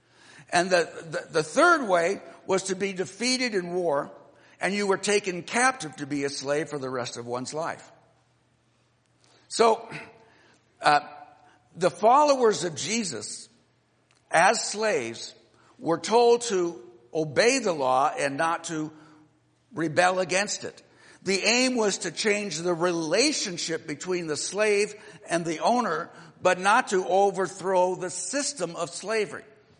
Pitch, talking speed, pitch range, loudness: 180 Hz, 135 wpm, 150-205 Hz, -25 LUFS